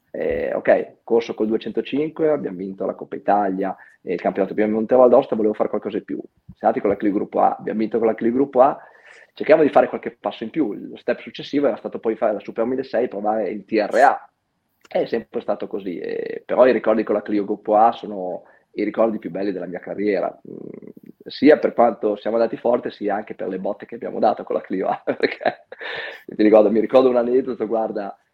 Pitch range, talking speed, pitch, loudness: 110-130 Hz, 220 wpm, 115 Hz, -20 LUFS